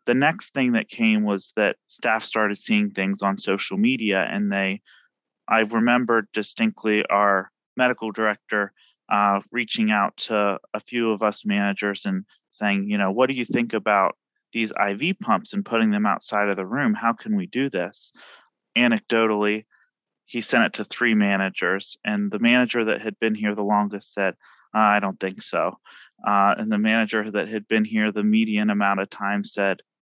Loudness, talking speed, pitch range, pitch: -23 LUFS, 180 wpm, 100-120 Hz, 110 Hz